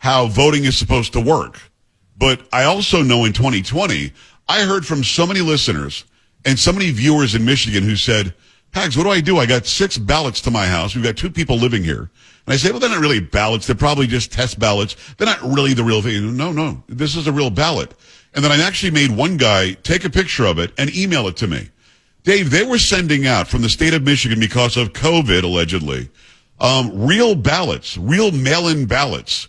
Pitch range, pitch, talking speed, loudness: 110-155 Hz, 130 Hz, 220 wpm, -16 LUFS